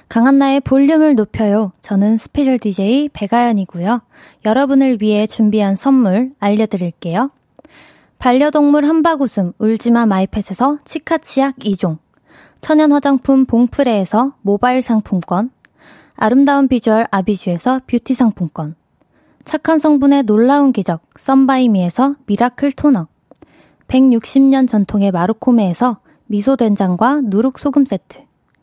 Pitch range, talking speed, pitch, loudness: 210-270 Hz, 285 characters per minute, 240 Hz, -14 LUFS